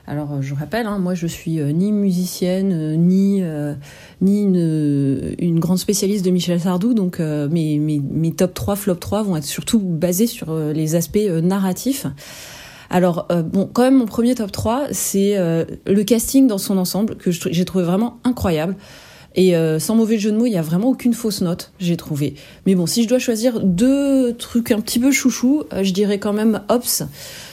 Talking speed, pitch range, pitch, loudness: 210 wpm, 170-225 Hz, 190 Hz, -18 LUFS